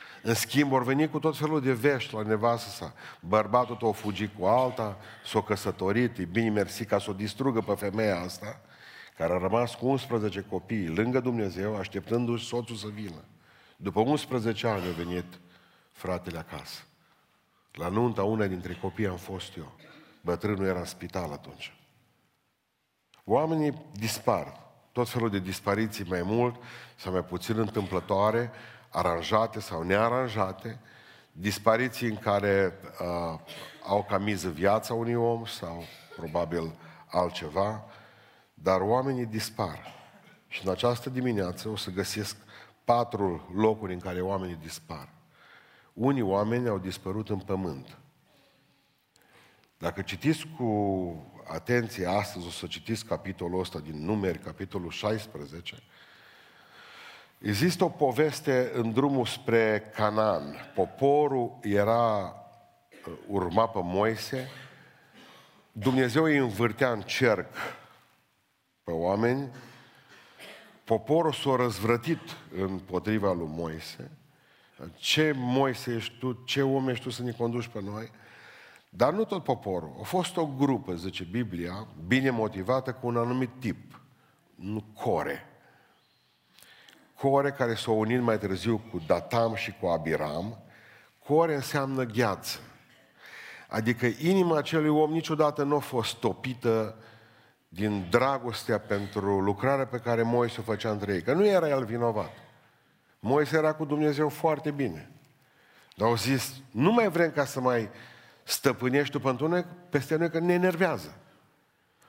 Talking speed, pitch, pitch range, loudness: 130 wpm, 115 Hz, 100-130 Hz, -29 LUFS